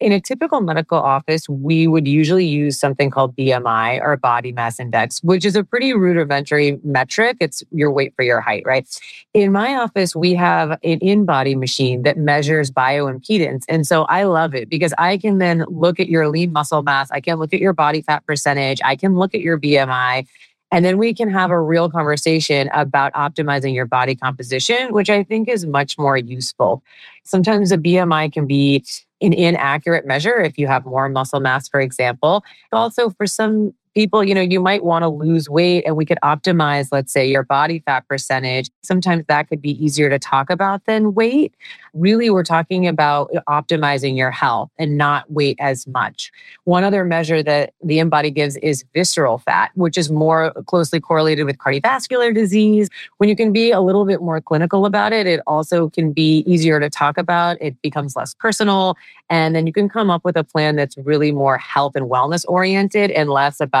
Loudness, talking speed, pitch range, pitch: -17 LUFS, 195 wpm, 140-185 Hz, 160 Hz